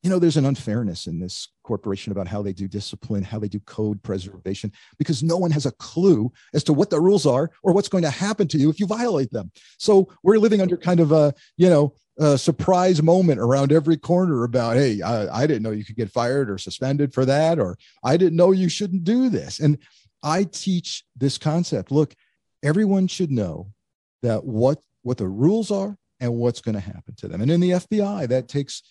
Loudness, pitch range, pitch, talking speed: -21 LUFS, 110-180 Hz, 145 Hz, 220 wpm